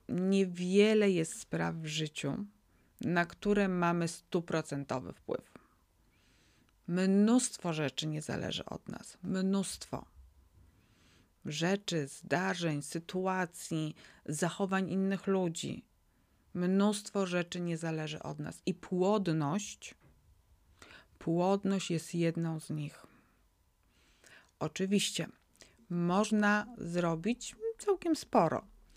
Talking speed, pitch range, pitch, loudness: 85 wpm, 155-195 Hz, 175 Hz, -33 LUFS